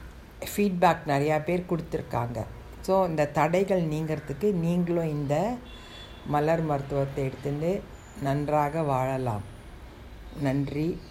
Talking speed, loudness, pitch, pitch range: 85 wpm, -27 LUFS, 150 Hz, 140-170 Hz